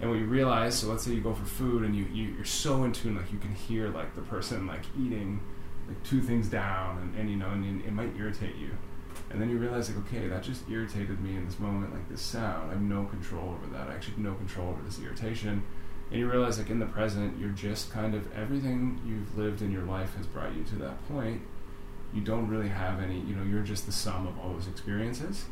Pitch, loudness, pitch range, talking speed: 100 Hz, -33 LUFS, 95-110 Hz, 255 wpm